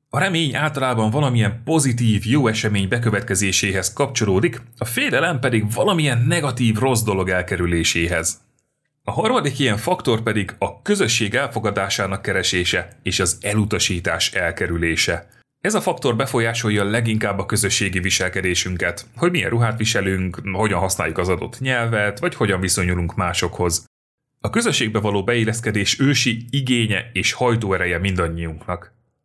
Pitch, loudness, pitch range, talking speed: 110 Hz, -19 LUFS, 95-125 Hz, 125 wpm